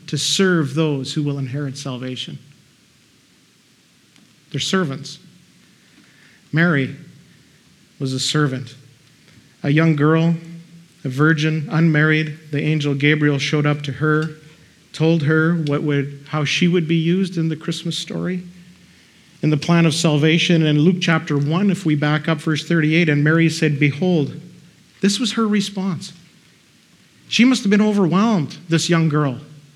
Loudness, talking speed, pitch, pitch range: -18 LUFS, 145 wpm, 155 Hz, 150-170 Hz